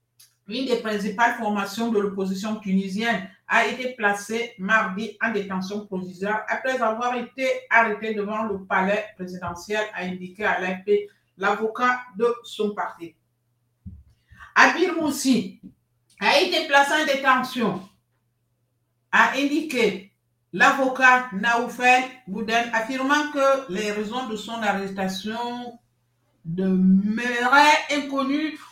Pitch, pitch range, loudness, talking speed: 215 Hz, 190-245 Hz, -22 LUFS, 105 wpm